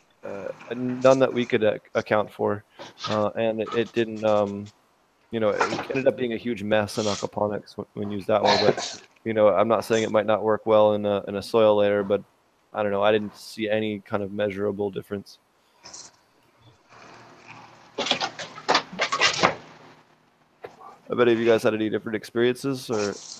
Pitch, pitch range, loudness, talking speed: 105 Hz, 105-115 Hz, -24 LUFS, 180 wpm